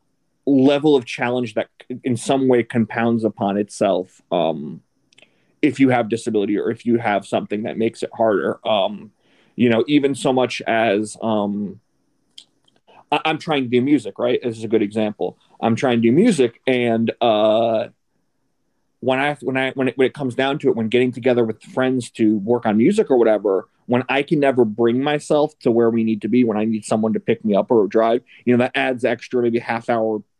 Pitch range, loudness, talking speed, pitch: 115-130 Hz, -19 LUFS, 205 wpm, 120 Hz